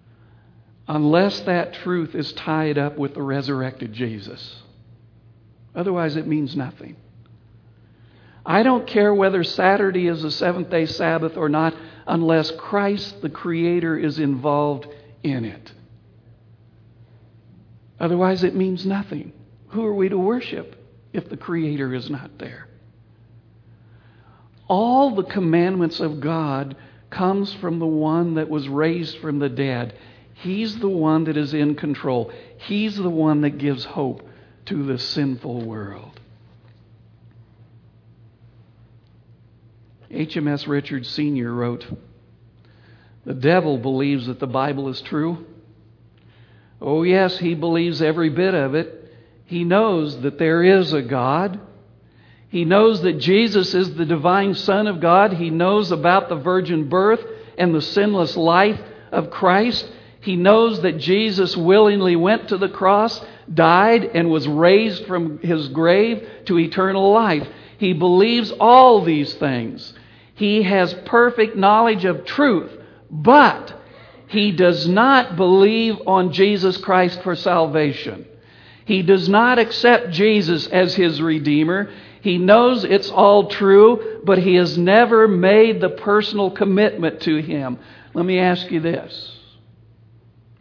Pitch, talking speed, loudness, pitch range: 165 Hz, 130 wpm, -18 LUFS, 130-190 Hz